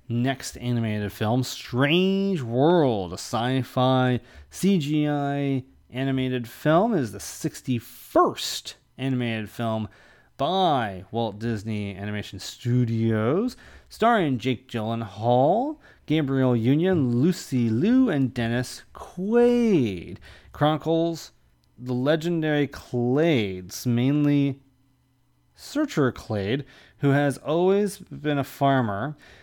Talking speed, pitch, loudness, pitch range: 90 wpm, 130 Hz, -24 LUFS, 115-150 Hz